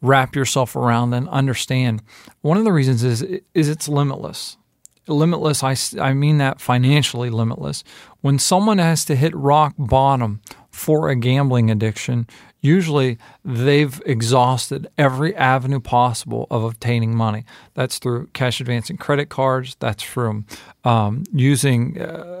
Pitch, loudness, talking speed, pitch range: 135 Hz, -19 LUFS, 135 wpm, 120-145 Hz